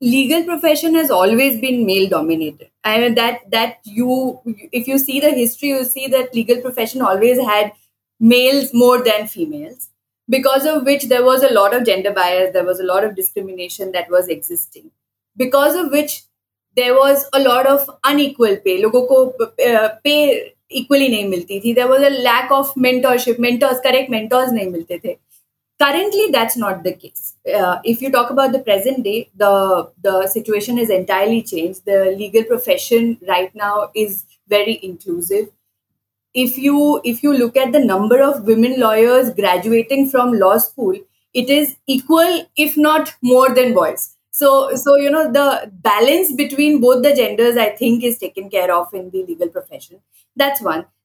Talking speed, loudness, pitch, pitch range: 170 wpm, -15 LUFS, 250 Hz, 210-280 Hz